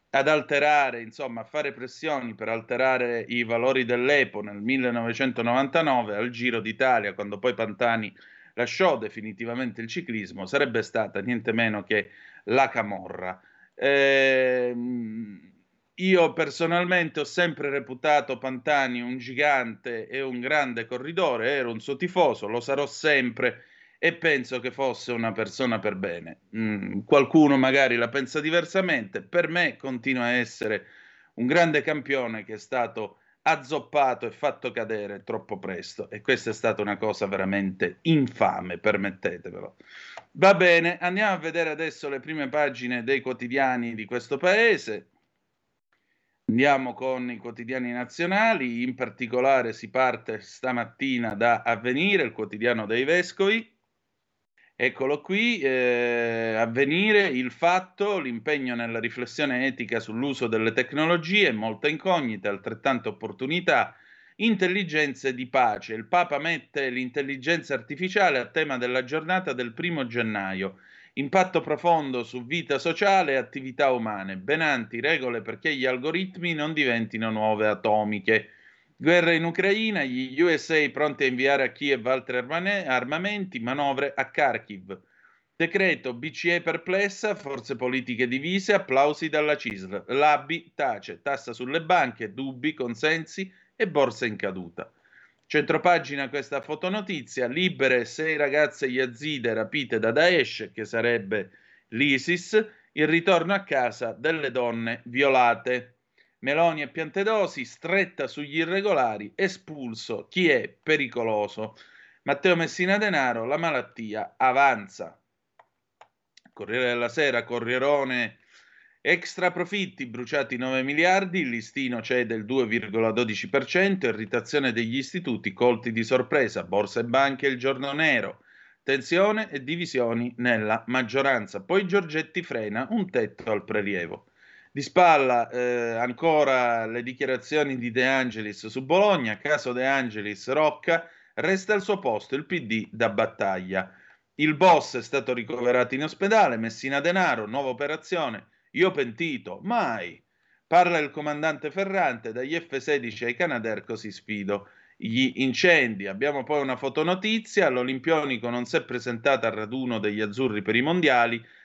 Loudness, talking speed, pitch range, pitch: -25 LUFS, 130 wpm, 120-160 Hz, 130 Hz